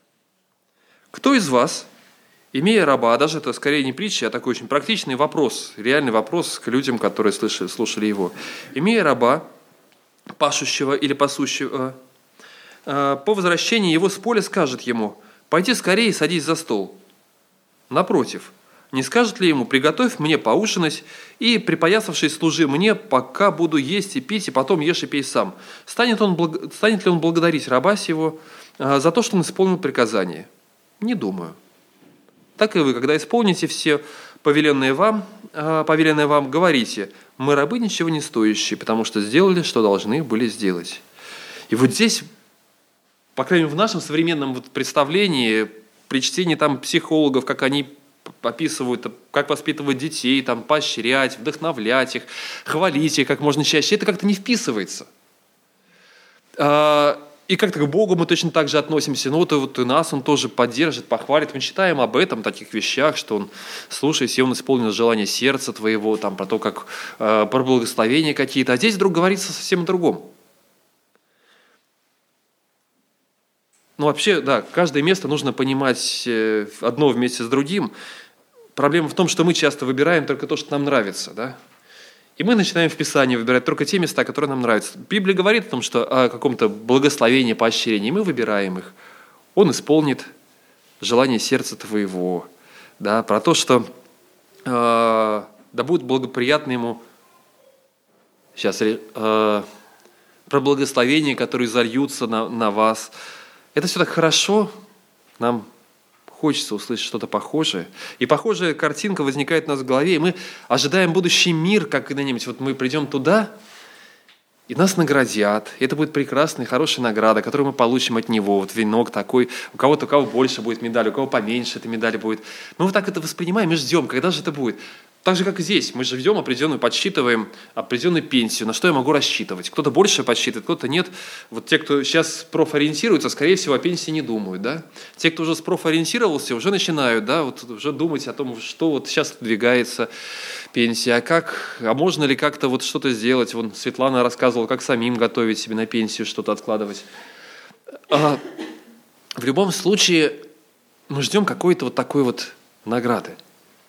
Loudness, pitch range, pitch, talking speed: -19 LUFS, 120-165 Hz, 145 Hz, 160 wpm